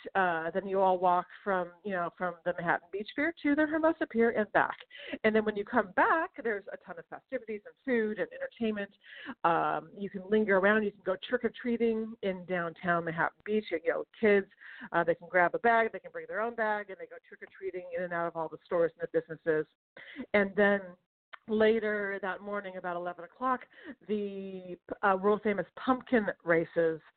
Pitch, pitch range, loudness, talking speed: 205 Hz, 180-230 Hz, -31 LUFS, 195 wpm